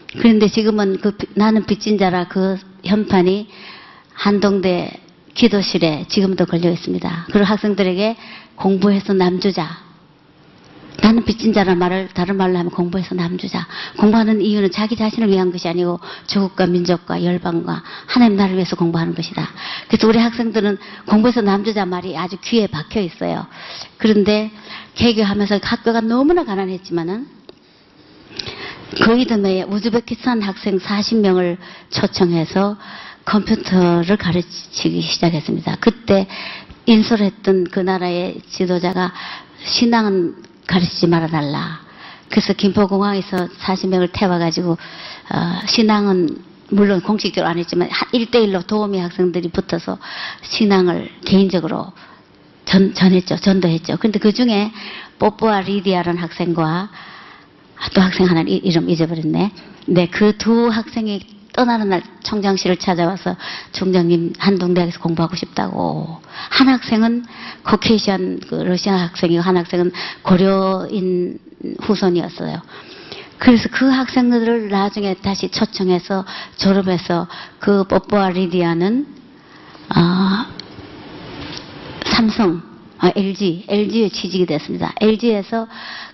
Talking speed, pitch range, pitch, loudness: 290 characters per minute, 180-215 Hz, 195 Hz, -17 LUFS